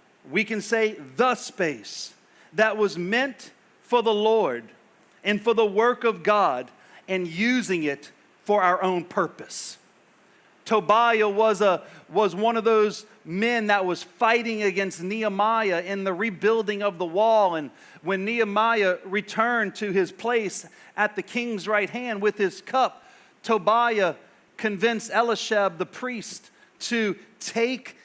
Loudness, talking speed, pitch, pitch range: -24 LUFS, 140 wpm, 210 Hz, 190-225 Hz